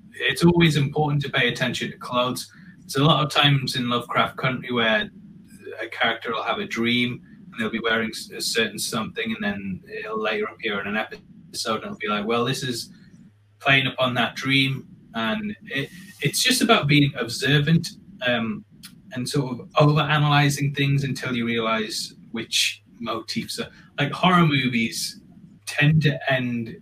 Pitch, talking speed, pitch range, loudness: 140 Hz, 170 wpm, 120-180 Hz, -22 LUFS